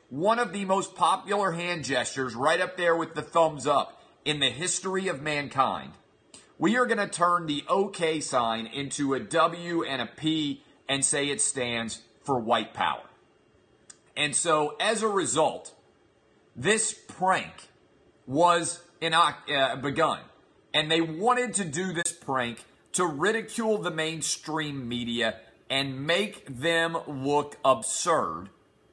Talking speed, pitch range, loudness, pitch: 140 wpm, 135-180 Hz, -27 LUFS, 160 Hz